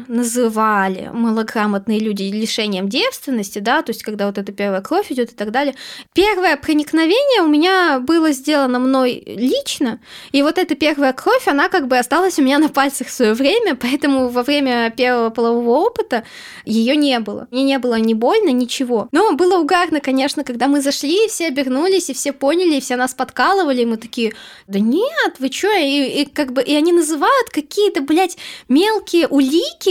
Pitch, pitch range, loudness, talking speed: 275 Hz, 240-325 Hz, -16 LUFS, 185 wpm